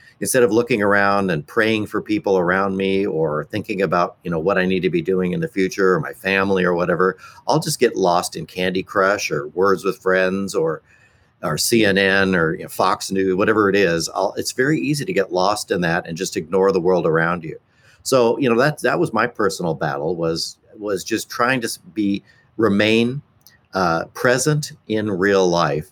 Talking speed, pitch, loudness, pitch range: 205 wpm, 95 Hz, -19 LUFS, 95-110 Hz